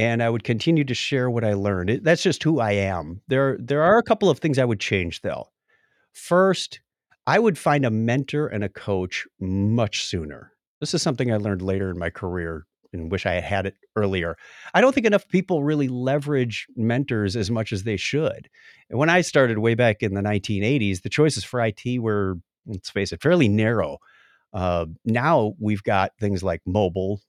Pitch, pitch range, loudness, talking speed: 115 Hz, 100-140 Hz, -22 LUFS, 200 wpm